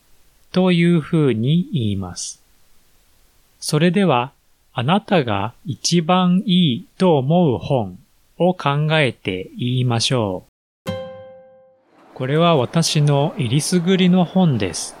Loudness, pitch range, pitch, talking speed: -18 LUFS, 110-180 Hz, 150 Hz, 200 characters per minute